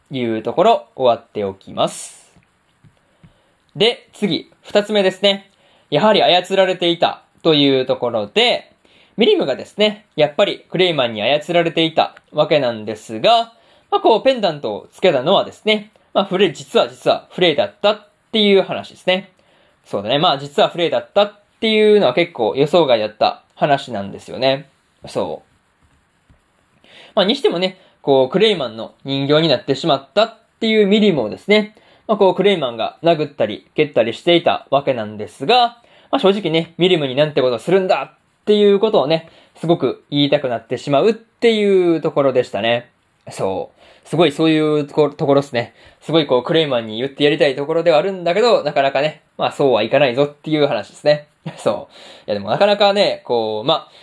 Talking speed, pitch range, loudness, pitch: 380 characters per minute, 140-205 Hz, -17 LUFS, 165 Hz